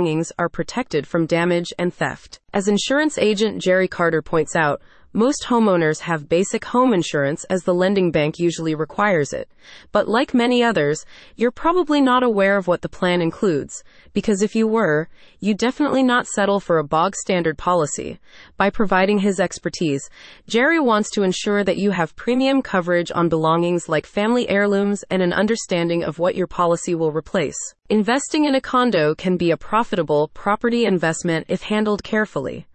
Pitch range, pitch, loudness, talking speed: 170-225 Hz, 185 Hz, -19 LUFS, 170 wpm